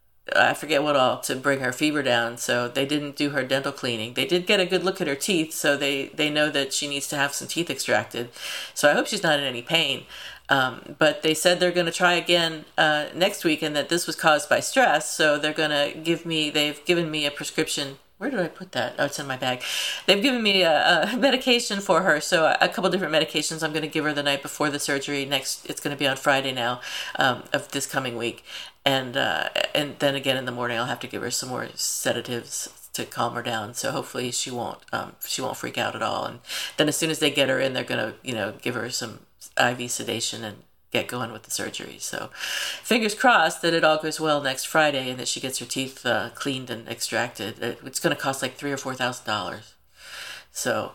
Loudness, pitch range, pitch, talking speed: -24 LUFS, 130-160 Hz, 145 Hz, 245 wpm